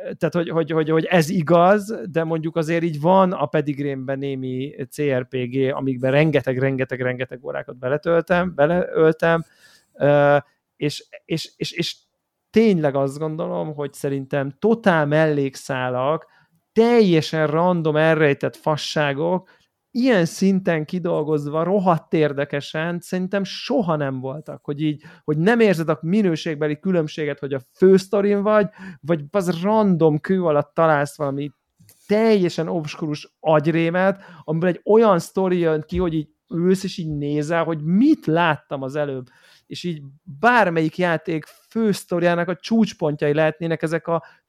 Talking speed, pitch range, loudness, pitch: 130 wpm, 145-180 Hz, -20 LUFS, 160 Hz